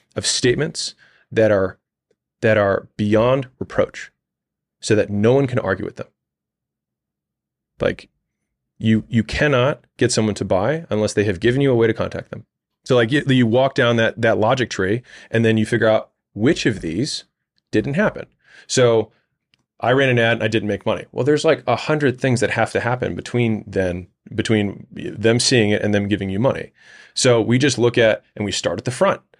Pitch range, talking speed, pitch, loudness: 105-125 Hz, 195 wpm, 115 Hz, -19 LUFS